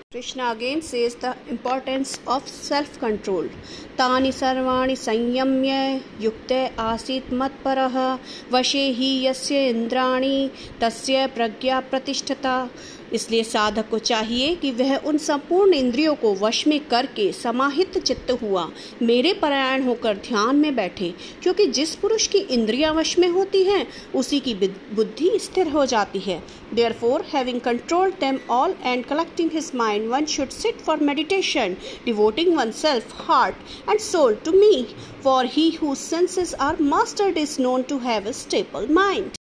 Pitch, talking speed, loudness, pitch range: 265 Hz, 135 wpm, -22 LUFS, 240-310 Hz